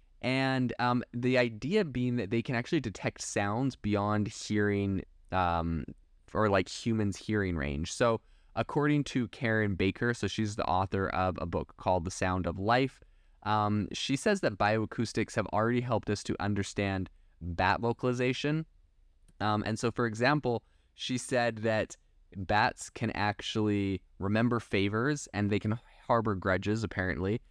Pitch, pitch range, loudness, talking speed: 105 Hz, 95-120 Hz, -31 LUFS, 150 wpm